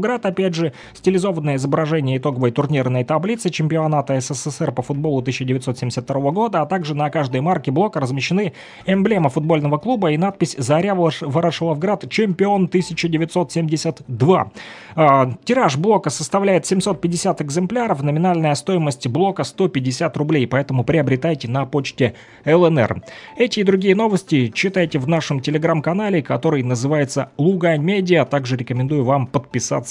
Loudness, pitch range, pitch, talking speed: -19 LUFS, 140-185 Hz, 155 Hz, 120 wpm